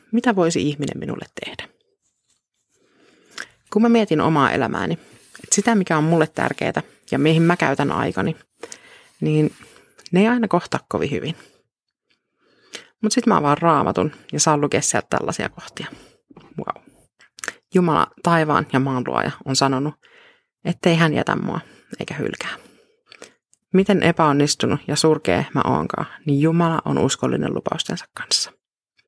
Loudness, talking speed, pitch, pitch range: -20 LUFS, 135 wpm, 165 Hz, 145-215 Hz